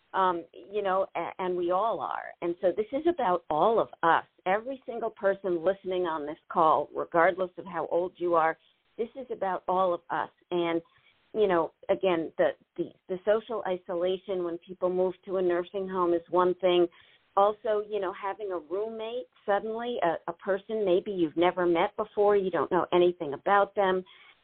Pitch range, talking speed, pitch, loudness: 175-200 Hz, 180 wpm, 185 Hz, -29 LUFS